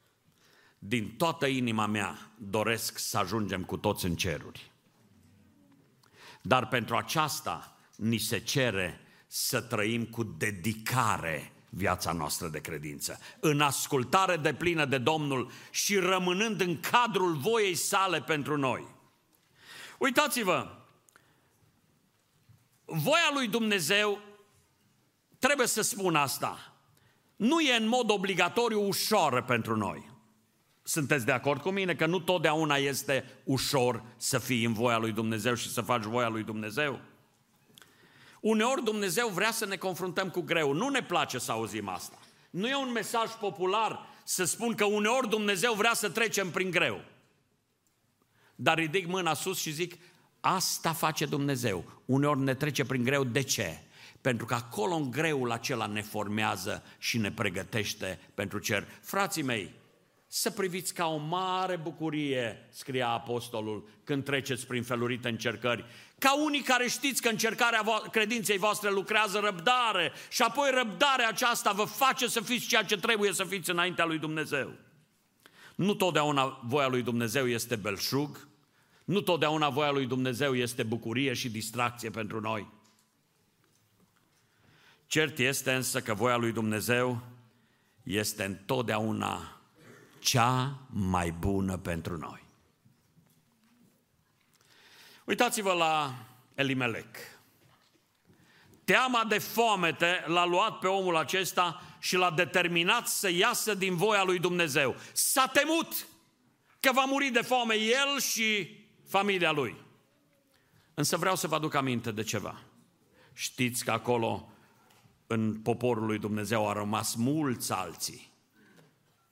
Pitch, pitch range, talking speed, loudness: 145 Hz, 115-195 Hz, 130 wpm, -29 LUFS